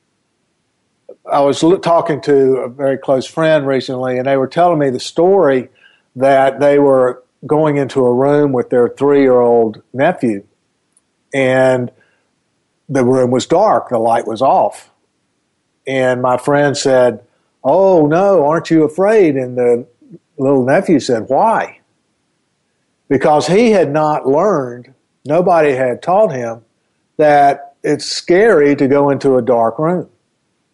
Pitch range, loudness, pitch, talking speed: 125-155 Hz, -13 LUFS, 135 Hz, 140 wpm